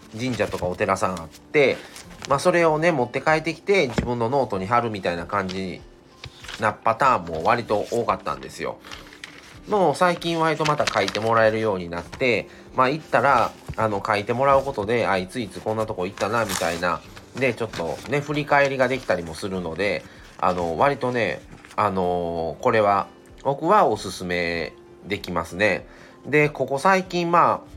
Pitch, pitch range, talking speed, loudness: 110 Hz, 90-140 Hz, 345 characters per minute, -22 LUFS